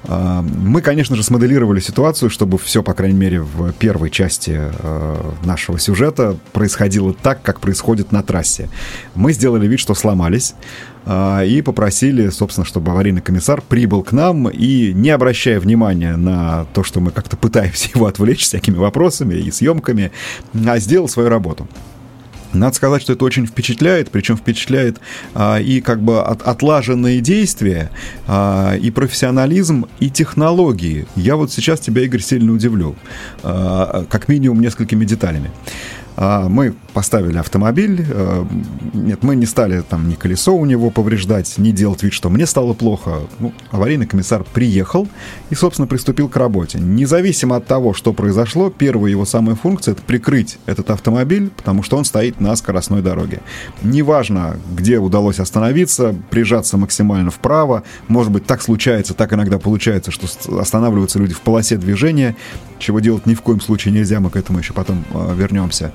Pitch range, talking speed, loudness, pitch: 95-125 Hz, 155 wpm, -15 LUFS, 110 Hz